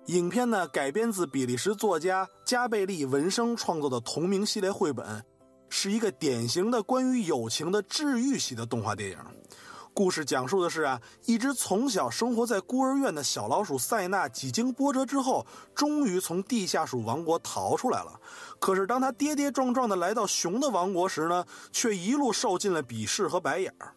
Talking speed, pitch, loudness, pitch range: 285 characters per minute, 195 Hz, -28 LUFS, 150-245 Hz